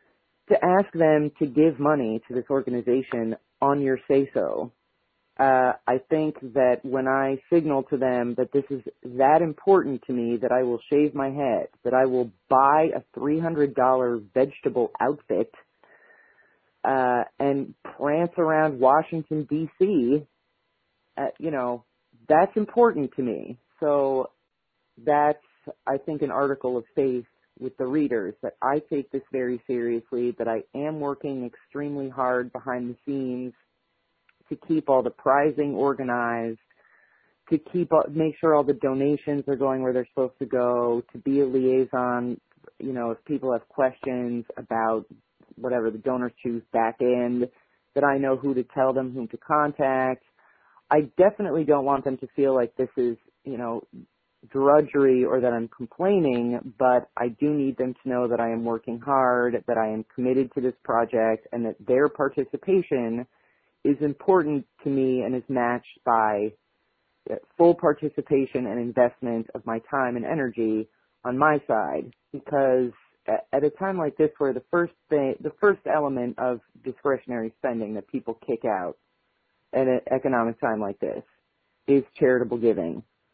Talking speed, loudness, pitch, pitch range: 160 wpm, -25 LUFS, 130 Hz, 120-145 Hz